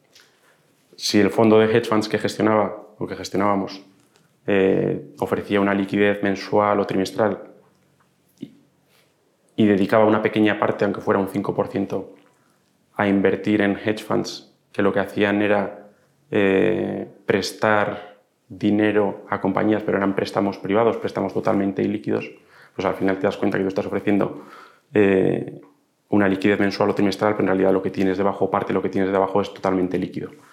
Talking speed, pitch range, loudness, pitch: 155 wpm, 95-105 Hz, -21 LUFS, 100 Hz